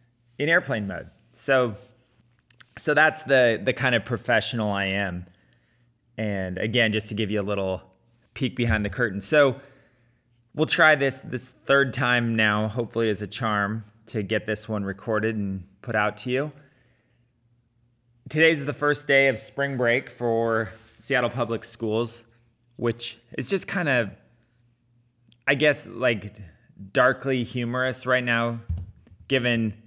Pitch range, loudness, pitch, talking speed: 110-130 Hz, -24 LUFS, 120 Hz, 145 wpm